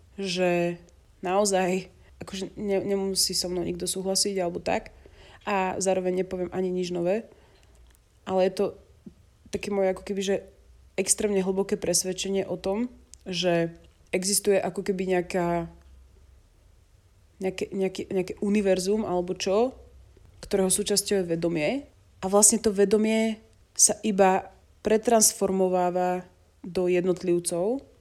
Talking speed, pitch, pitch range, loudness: 105 wpm, 190 Hz, 180-200 Hz, -26 LUFS